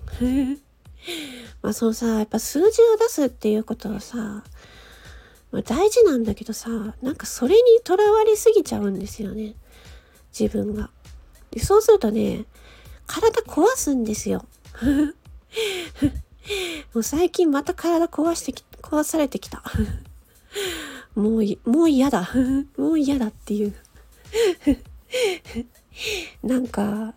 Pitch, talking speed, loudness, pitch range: 275 Hz, 225 characters per minute, -22 LUFS, 225-370 Hz